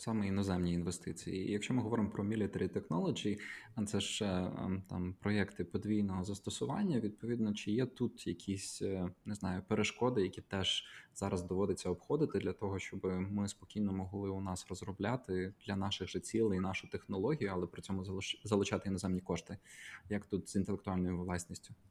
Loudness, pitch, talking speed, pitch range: -38 LUFS, 100 Hz, 150 wpm, 95-105 Hz